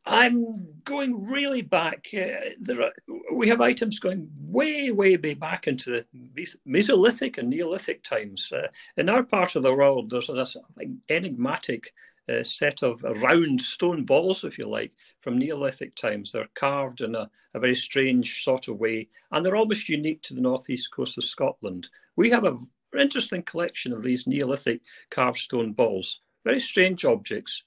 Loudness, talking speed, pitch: -25 LUFS, 170 wpm, 185 Hz